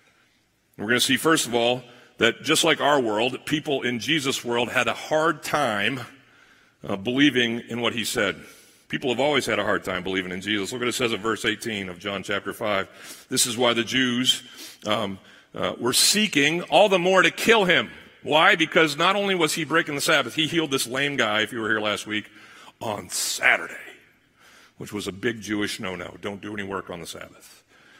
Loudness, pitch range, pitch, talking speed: -22 LUFS, 105-145 Hz, 120 Hz, 210 wpm